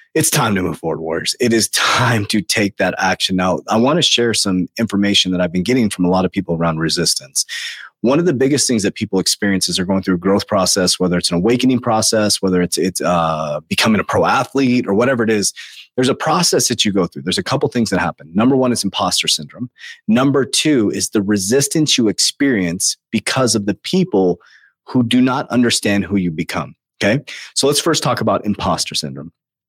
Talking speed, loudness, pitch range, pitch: 215 wpm, -16 LUFS, 90-120 Hz, 105 Hz